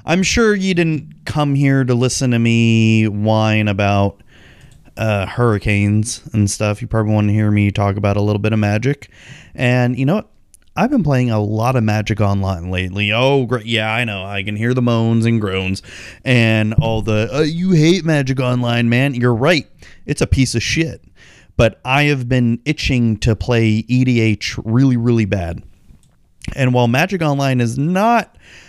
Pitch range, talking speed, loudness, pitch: 105-130 Hz, 180 wpm, -16 LUFS, 115 Hz